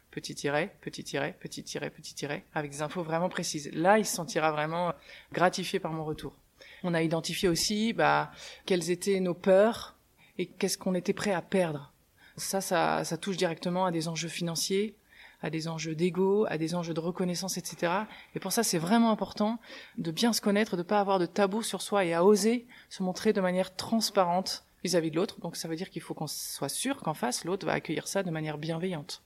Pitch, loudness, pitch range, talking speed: 180 Hz, -30 LUFS, 165-200 Hz, 215 wpm